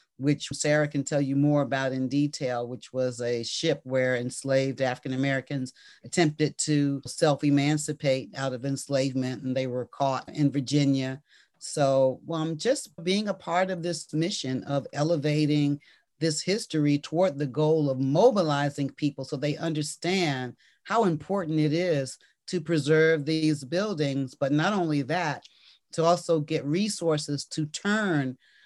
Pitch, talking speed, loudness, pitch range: 145 Hz, 145 wpm, -27 LUFS, 135-160 Hz